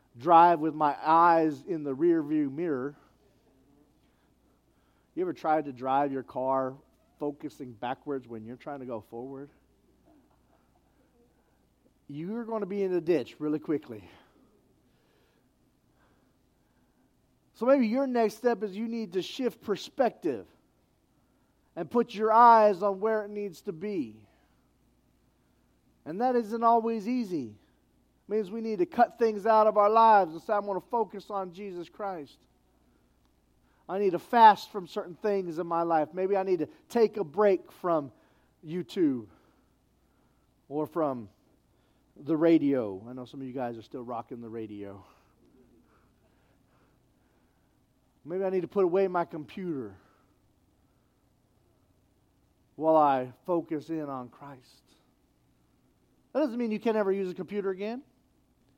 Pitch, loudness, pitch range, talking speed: 170 Hz, -28 LUFS, 130-215 Hz, 140 wpm